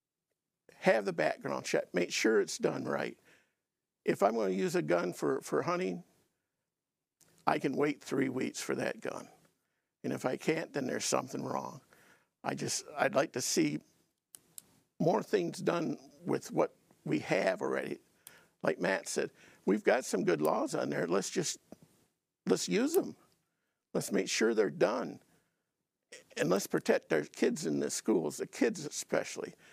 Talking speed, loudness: 165 wpm, -33 LUFS